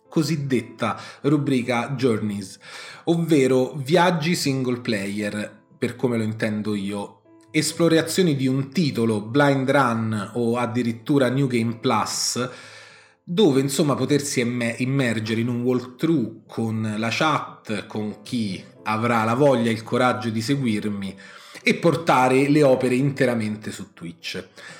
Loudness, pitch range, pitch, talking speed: -22 LUFS, 110-140 Hz, 125 Hz, 120 wpm